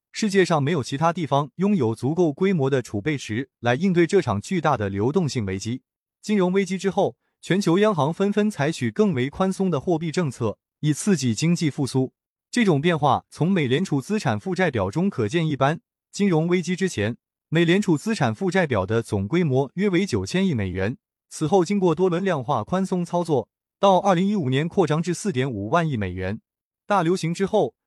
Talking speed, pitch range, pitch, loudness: 300 characters per minute, 130-190 Hz, 165 Hz, -23 LUFS